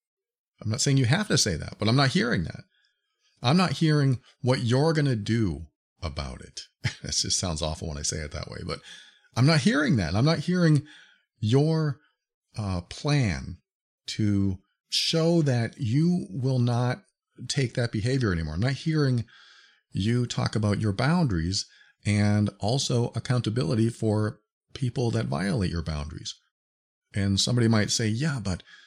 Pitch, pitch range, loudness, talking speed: 120 Hz, 100-145 Hz, -26 LUFS, 160 wpm